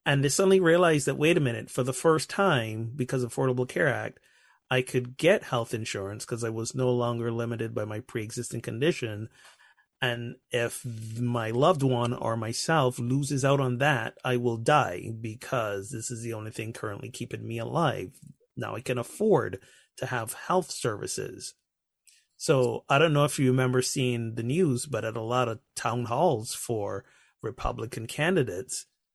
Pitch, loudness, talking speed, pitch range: 125 Hz, -28 LUFS, 175 wpm, 115-135 Hz